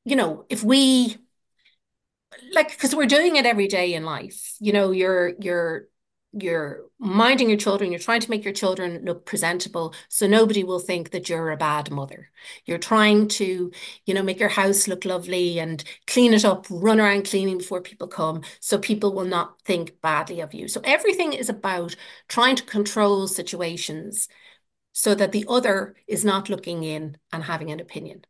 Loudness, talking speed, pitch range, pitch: -22 LUFS, 180 wpm, 175-215 Hz, 195 Hz